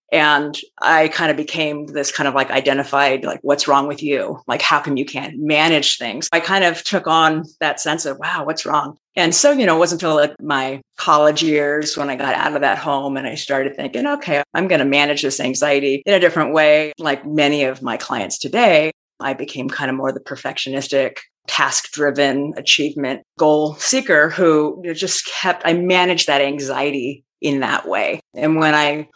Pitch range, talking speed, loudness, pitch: 140-160 Hz, 200 wpm, -17 LUFS, 150 Hz